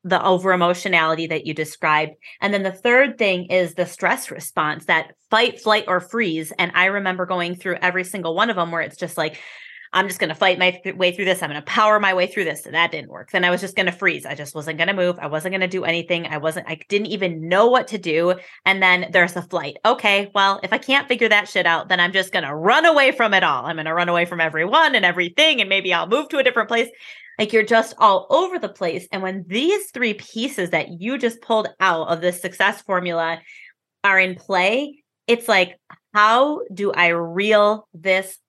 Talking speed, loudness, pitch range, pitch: 245 wpm, -19 LUFS, 175-215 Hz, 185 Hz